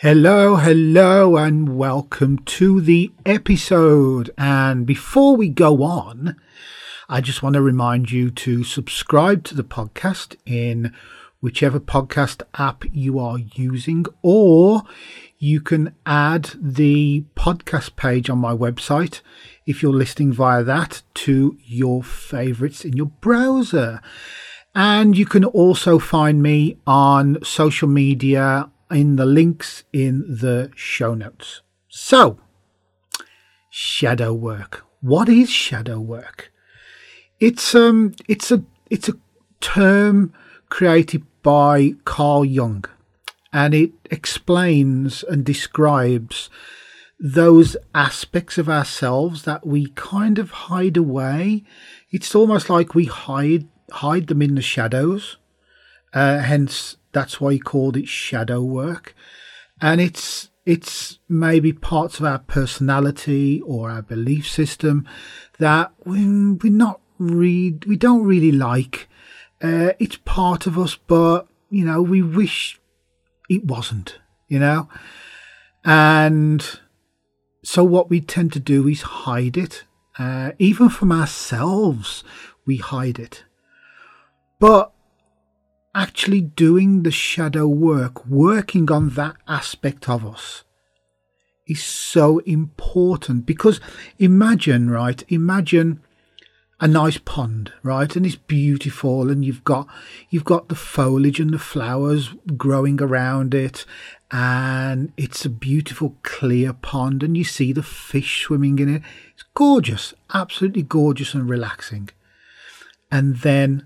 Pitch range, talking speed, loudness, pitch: 135-175 Hz, 120 wpm, -17 LUFS, 145 Hz